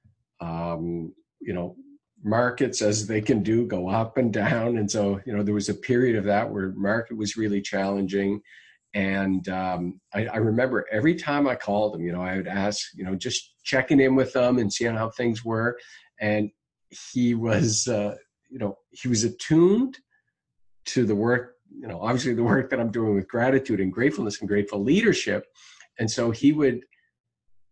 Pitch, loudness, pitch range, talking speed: 110 Hz, -25 LUFS, 100-125 Hz, 185 wpm